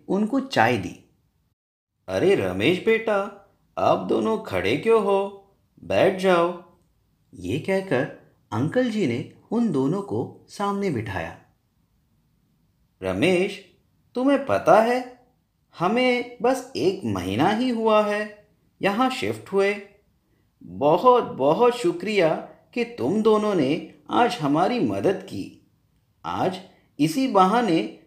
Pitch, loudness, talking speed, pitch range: 210 Hz, -23 LUFS, 110 wpm, 190-240 Hz